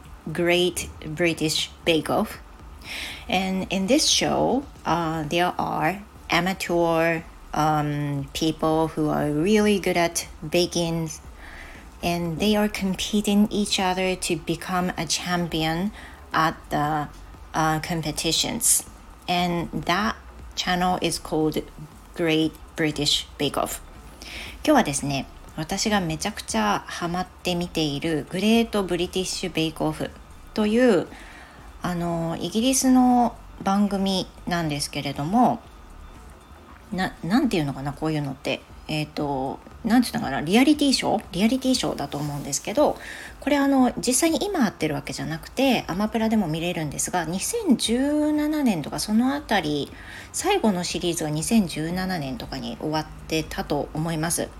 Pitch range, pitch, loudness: 150-205 Hz, 170 Hz, -24 LUFS